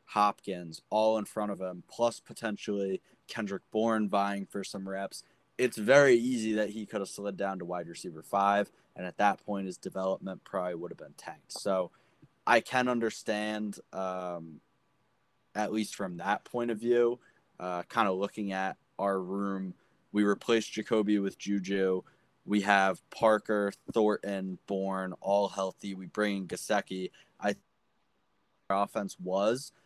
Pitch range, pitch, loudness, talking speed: 95-110 Hz, 100 Hz, -31 LUFS, 155 wpm